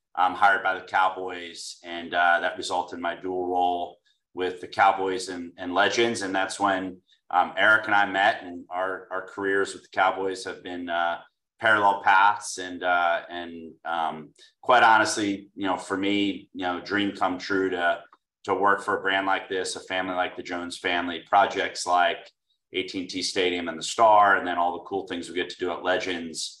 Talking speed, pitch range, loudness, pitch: 200 wpm, 85-95 Hz, -25 LUFS, 90 Hz